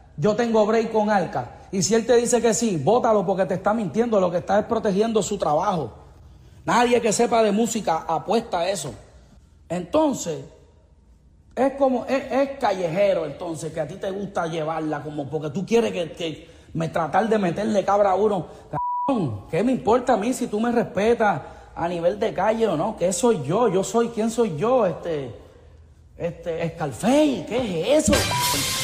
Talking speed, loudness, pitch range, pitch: 185 wpm, -22 LUFS, 160-230 Hz, 200 Hz